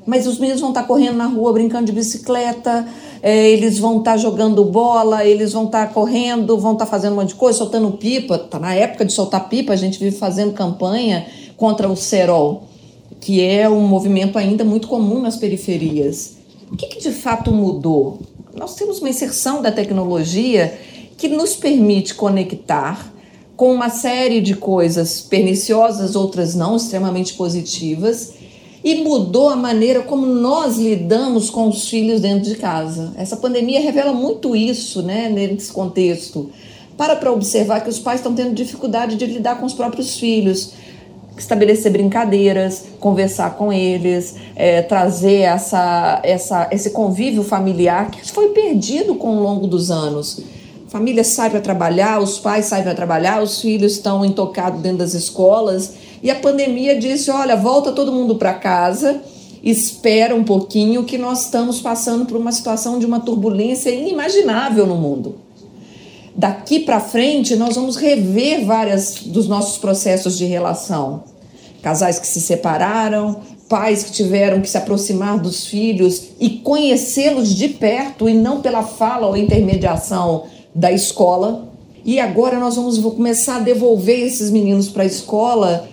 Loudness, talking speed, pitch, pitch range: -16 LUFS, 155 wpm, 215 Hz, 195-240 Hz